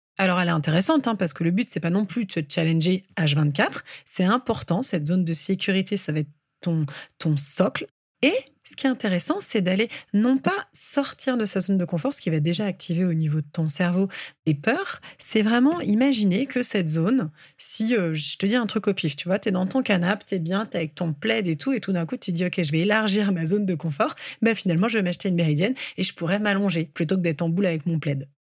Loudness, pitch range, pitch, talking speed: -23 LUFS, 165-215 Hz, 185 Hz, 255 wpm